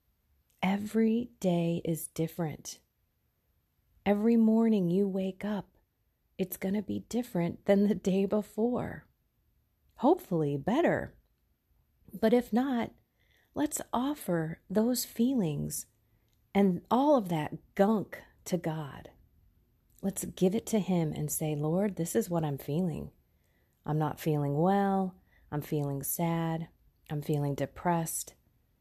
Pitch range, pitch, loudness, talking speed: 150-210 Hz, 180 Hz, -31 LUFS, 120 wpm